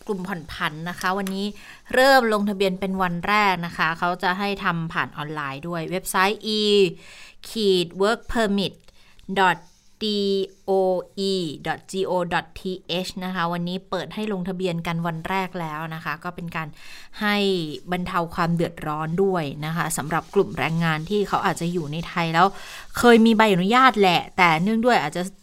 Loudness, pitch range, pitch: -22 LUFS, 170-195 Hz, 185 Hz